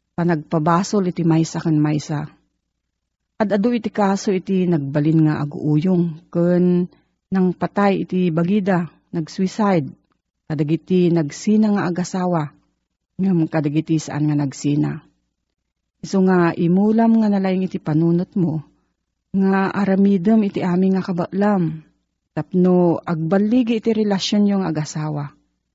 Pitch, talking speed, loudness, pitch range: 175 Hz, 110 wpm, -19 LUFS, 155-195 Hz